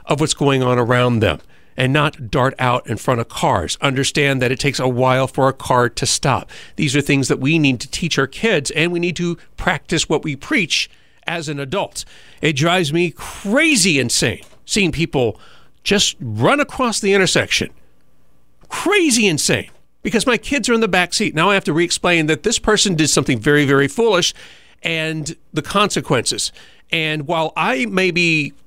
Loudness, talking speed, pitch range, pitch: -17 LUFS, 185 wpm, 135-180 Hz, 155 Hz